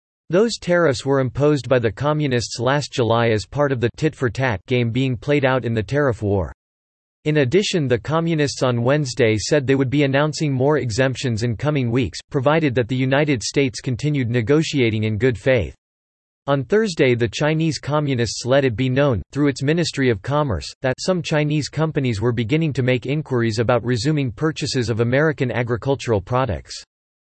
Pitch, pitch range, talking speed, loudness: 130 Hz, 120-150 Hz, 175 wpm, -20 LUFS